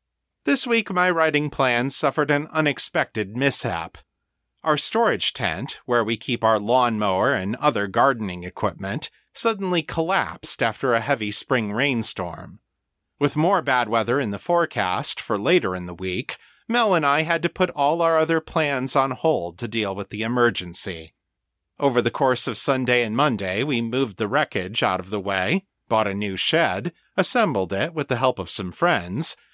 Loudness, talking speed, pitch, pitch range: -21 LUFS, 170 wpm, 125 Hz, 100-155 Hz